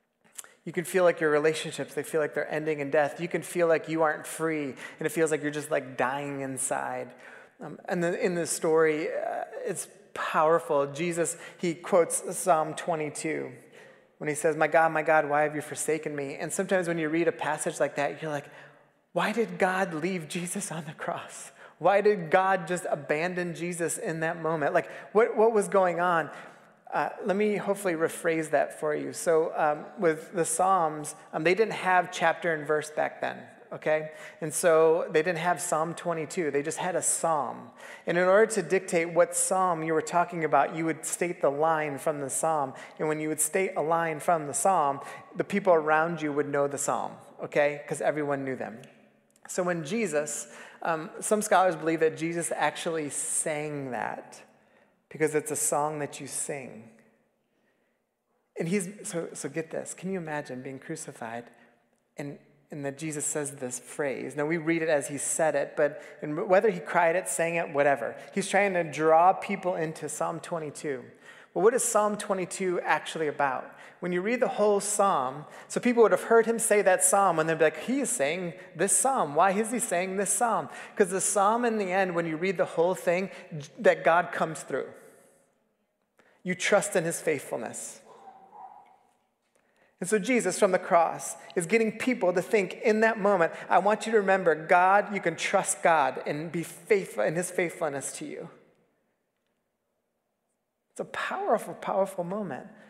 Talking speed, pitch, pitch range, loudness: 190 wpm, 170 Hz, 155-190 Hz, -27 LUFS